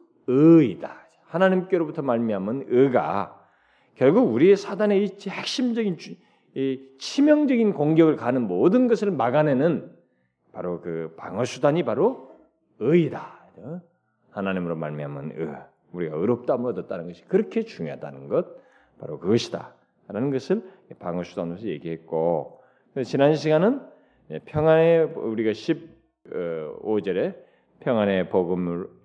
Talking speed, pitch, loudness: 265 characters per minute, 155 Hz, -23 LUFS